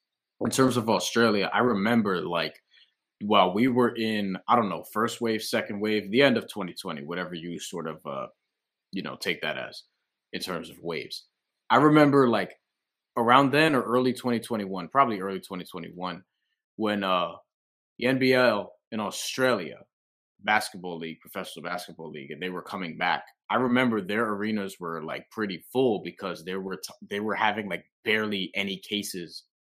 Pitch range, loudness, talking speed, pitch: 95-120 Hz, -26 LUFS, 165 wpm, 105 Hz